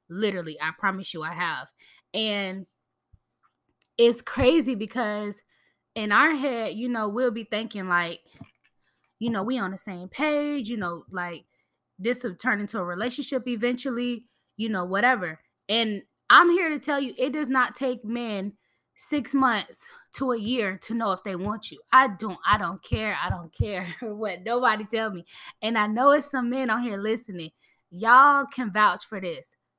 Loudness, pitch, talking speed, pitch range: -25 LUFS, 225 Hz, 175 wpm, 195-255 Hz